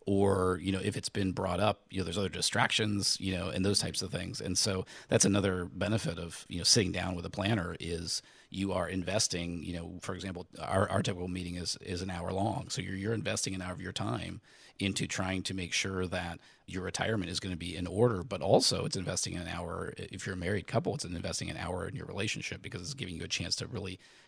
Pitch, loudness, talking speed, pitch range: 95 Hz, -33 LUFS, 245 wpm, 90-100 Hz